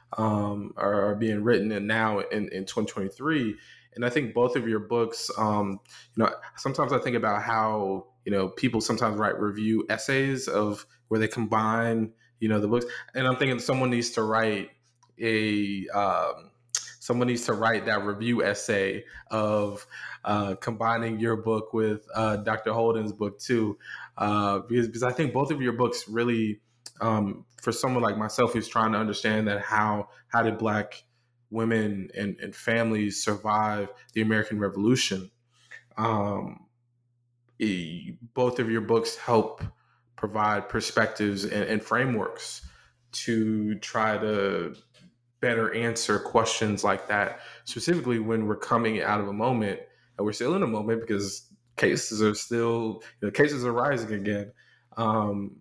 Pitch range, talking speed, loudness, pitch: 105-120 Hz, 155 wpm, -27 LUFS, 110 Hz